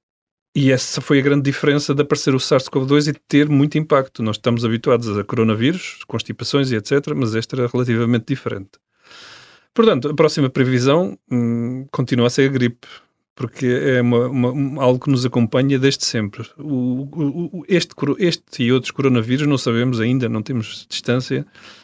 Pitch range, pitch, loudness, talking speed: 120-145 Hz, 130 Hz, -18 LUFS, 170 wpm